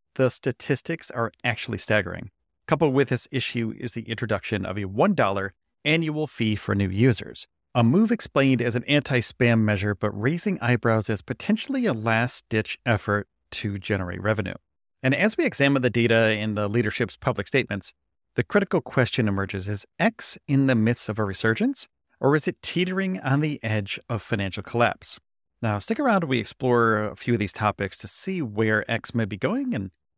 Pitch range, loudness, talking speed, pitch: 105-140 Hz, -24 LUFS, 185 wpm, 120 Hz